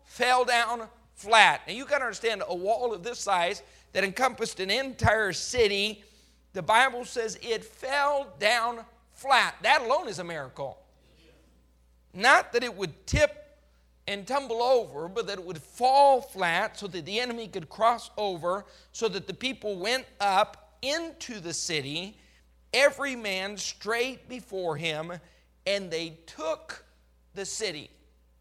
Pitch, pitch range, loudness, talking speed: 220 Hz, 185-250 Hz, -27 LUFS, 150 wpm